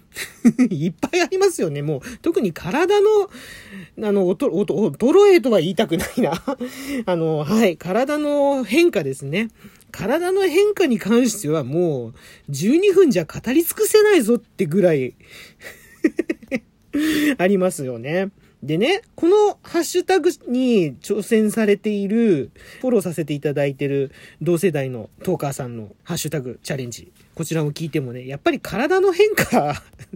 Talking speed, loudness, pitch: 295 characters per minute, -19 LUFS, 210 Hz